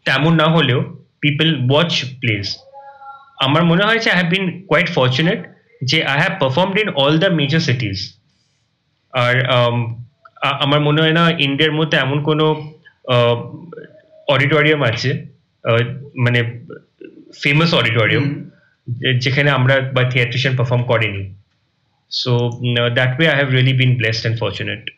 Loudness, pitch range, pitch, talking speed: -16 LUFS, 125-160 Hz, 140 Hz, 125 wpm